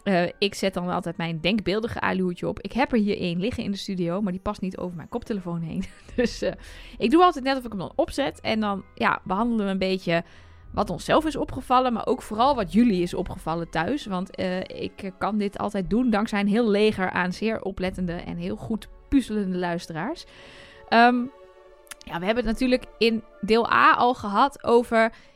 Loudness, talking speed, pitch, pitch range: -24 LUFS, 205 wpm, 205 Hz, 185-235 Hz